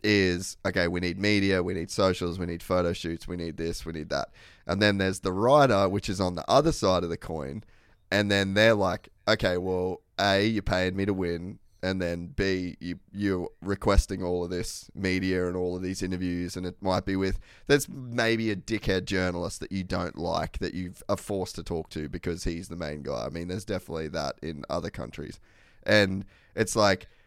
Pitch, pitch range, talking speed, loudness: 95 Hz, 90-100 Hz, 210 wpm, -28 LUFS